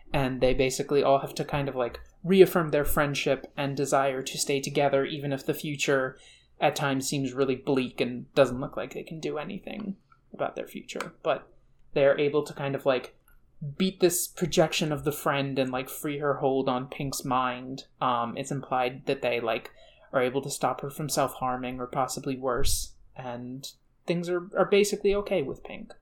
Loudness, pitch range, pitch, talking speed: -28 LUFS, 130-150 Hz, 140 Hz, 190 wpm